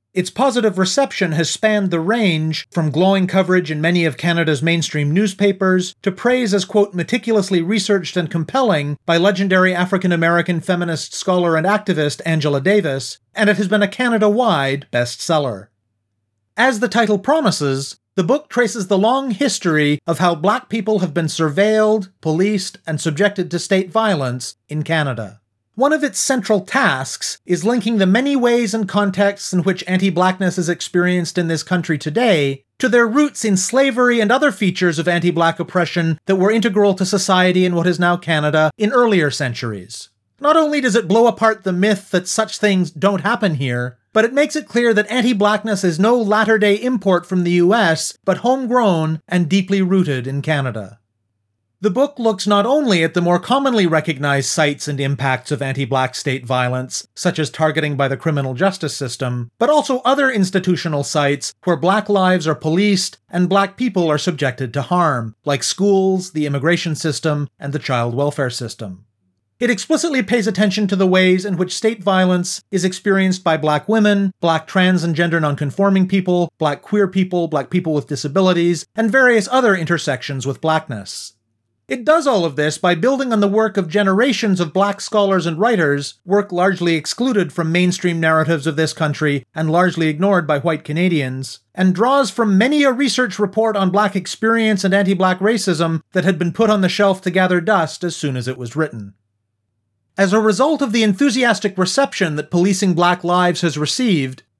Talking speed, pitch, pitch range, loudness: 180 wpm, 180 Hz, 155-210 Hz, -17 LUFS